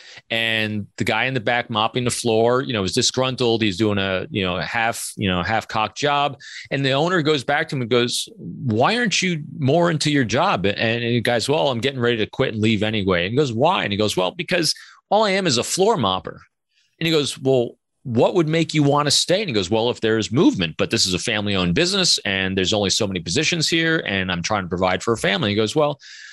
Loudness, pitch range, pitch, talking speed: -20 LUFS, 105-150 Hz, 120 Hz, 260 wpm